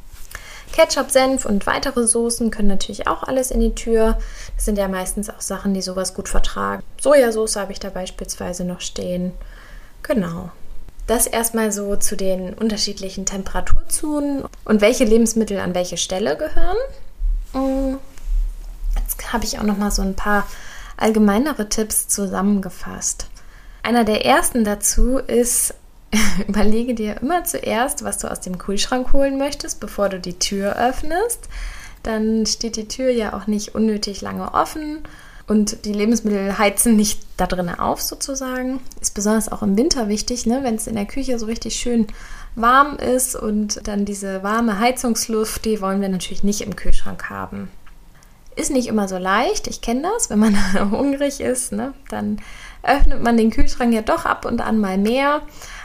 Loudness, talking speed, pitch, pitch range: -20 LUFS, 160 wpm, 220 Hz, 200-250 Hz